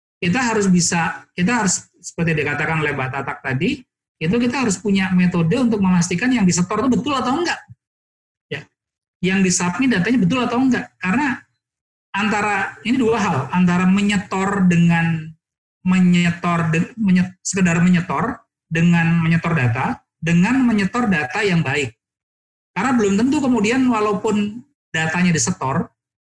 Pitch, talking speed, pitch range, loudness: 185 Hz, 135 wpm, 165-220 Hz, -18 LUFS